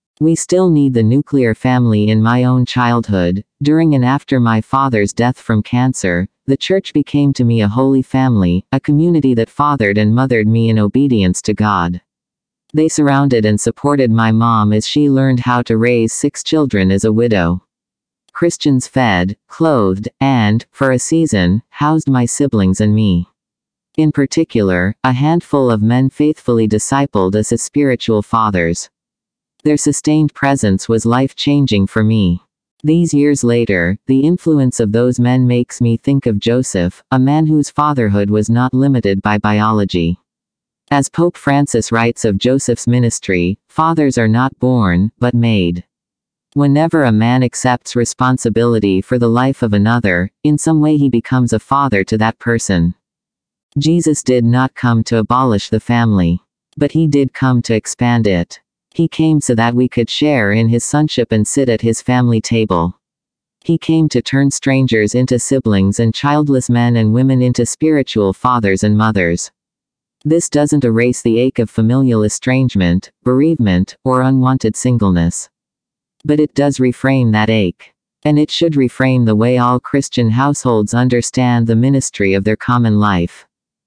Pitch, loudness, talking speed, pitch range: 120 Hz, -13 LUFS, 160 wpm, 110-140 Hz